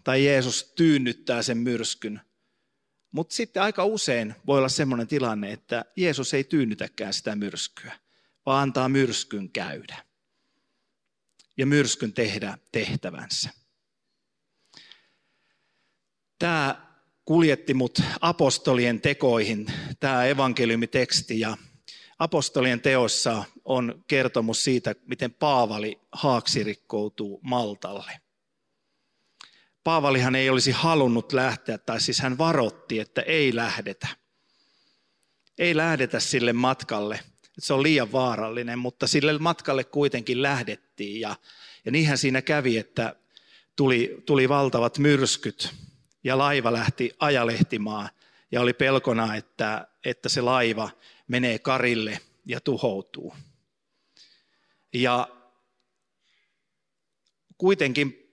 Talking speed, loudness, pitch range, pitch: 100 wpm, -25 LUFS, 115-140 Hz, 130 Hz